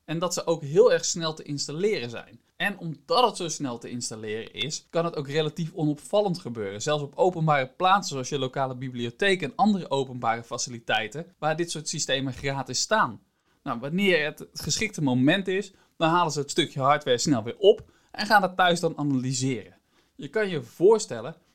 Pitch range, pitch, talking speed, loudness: 130-180 Hz, 155 Hz, 185 wpm, -26 LUFS